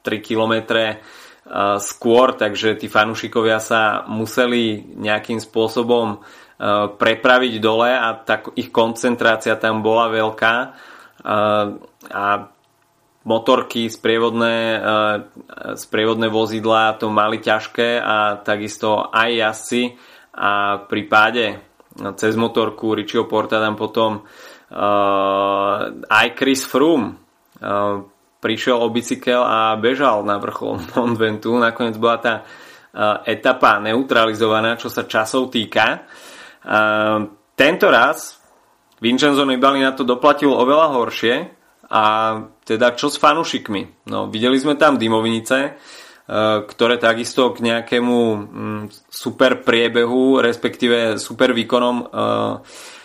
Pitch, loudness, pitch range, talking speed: 115 Hz, -17 LUFS, 110-120 Hz, 110 wpm